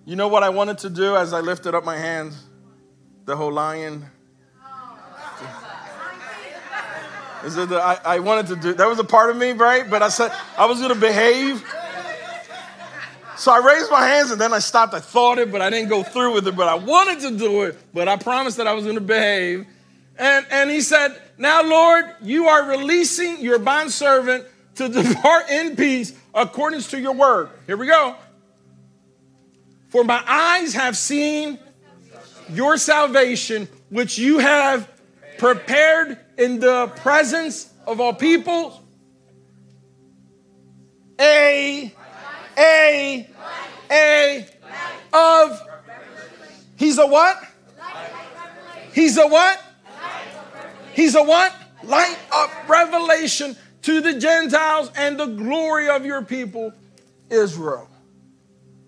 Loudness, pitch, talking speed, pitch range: -17 LUFS, 250 Hz, 140 wpm, 190-300 Hz